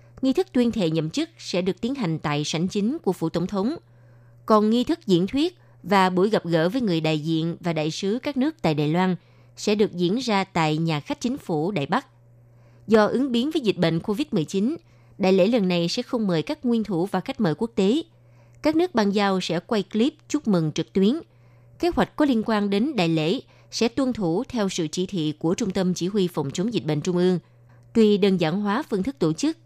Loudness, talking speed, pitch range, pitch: -23 LUFS, 235 wpm, 160-230 Hz, 185 Hz